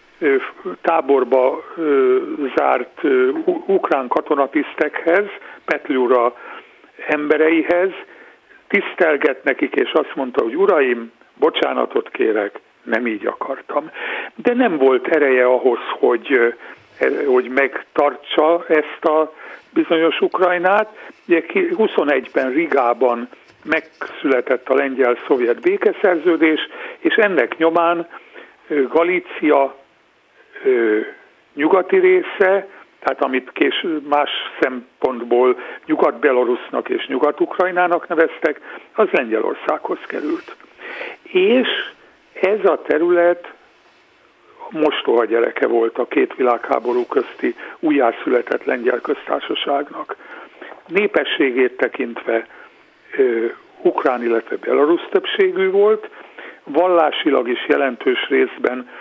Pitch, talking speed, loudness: 350 Hz, 80 wpm, -18 LUFS